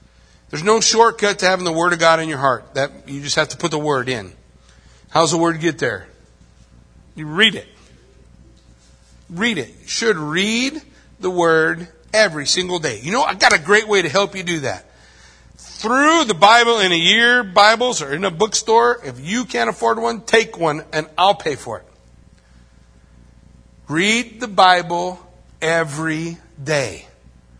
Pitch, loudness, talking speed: 165 Hz, -16 LUFS, 170 wpm